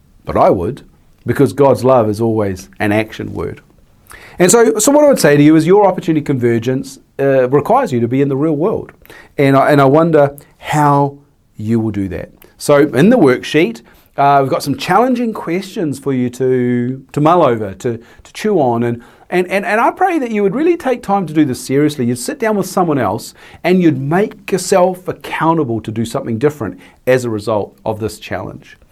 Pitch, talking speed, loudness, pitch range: 140 Hz, 205 wpm, -14 LUFS, 120-180 Hz